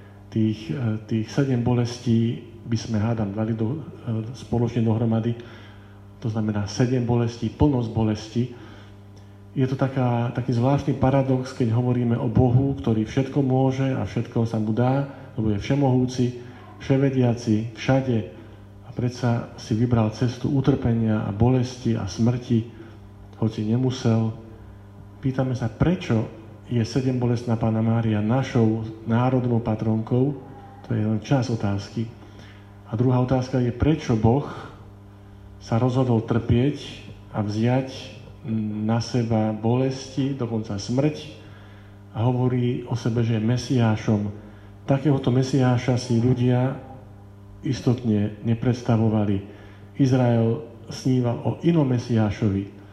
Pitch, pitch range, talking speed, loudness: 115 Hz, 110-125 Hz, 115 wpm, -23 LUFS